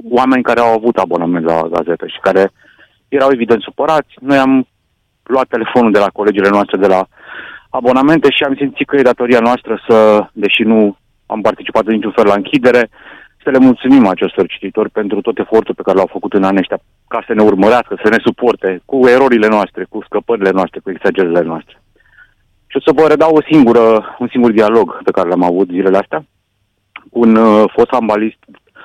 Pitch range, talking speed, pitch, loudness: 100-125 Hz, 190 wpm, 110 Hz, -12 LUFS